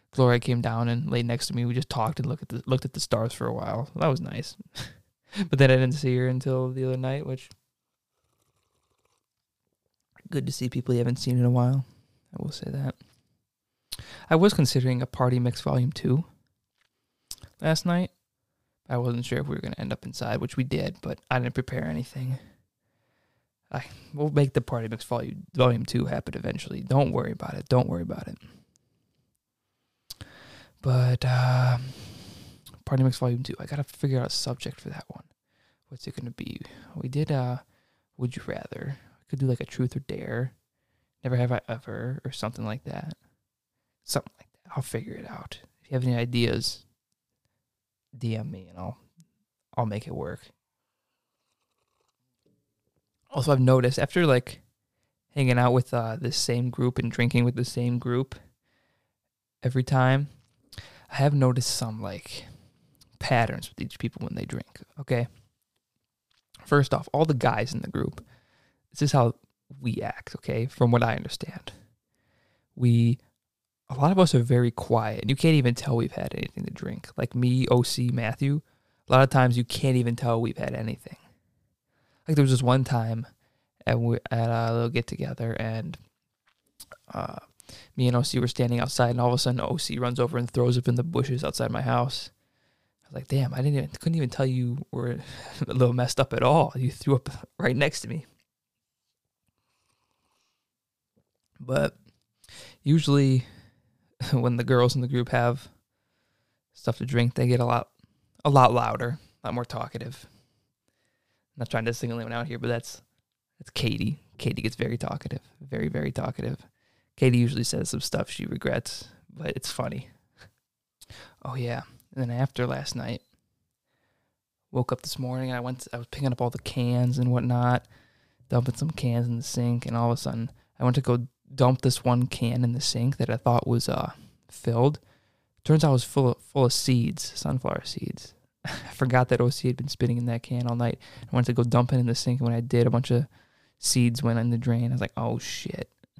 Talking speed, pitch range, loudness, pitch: 185 wpm, 120-130 Hz, -26 LUFS, 125 Hz